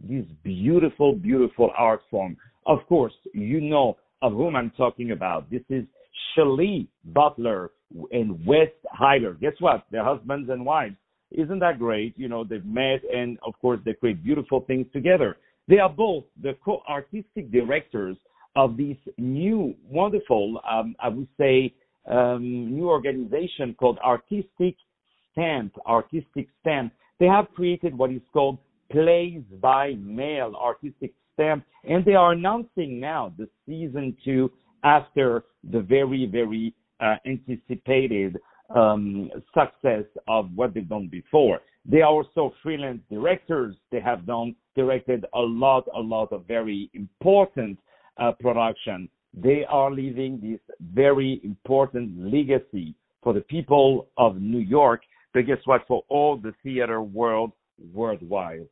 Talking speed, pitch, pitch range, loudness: 140 wpm, 130 Hz, 115-150 Hz, -24 LUFS